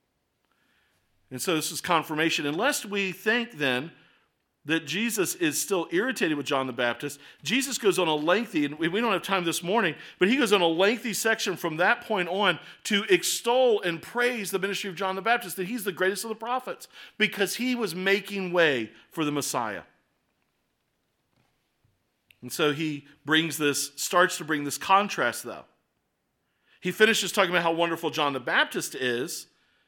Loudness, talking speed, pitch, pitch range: -26 LUFS, 175 wpm, 180 Hz, 150-205 Hz